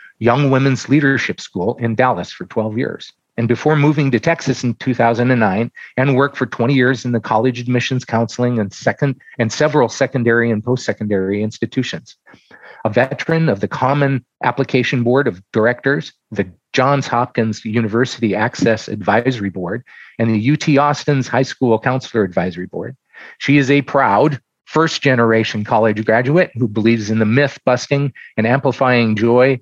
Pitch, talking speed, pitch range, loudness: 125 Hz, 150 wpm, 115-135 Hz, -16 LUFS